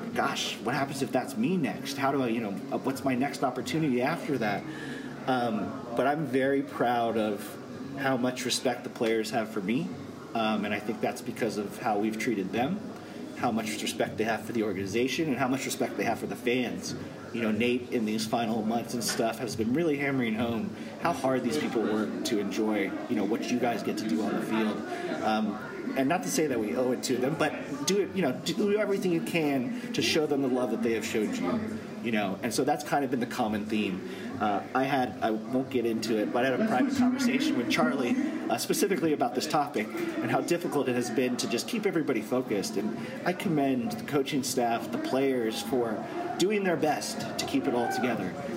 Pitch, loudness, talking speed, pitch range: 130 Hz, -29 LUFS, 225 wpm, 115-180 Hz